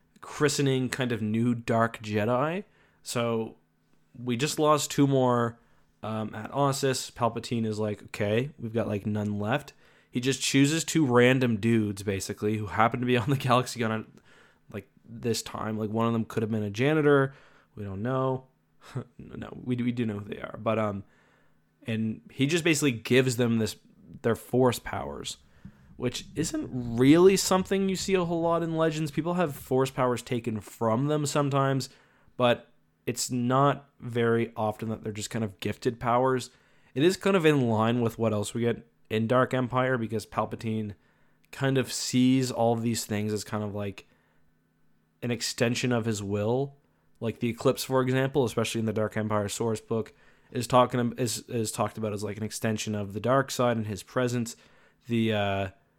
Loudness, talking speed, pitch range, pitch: -27 LUFS, 180 wpm, 110-130 Hz, 120 Hz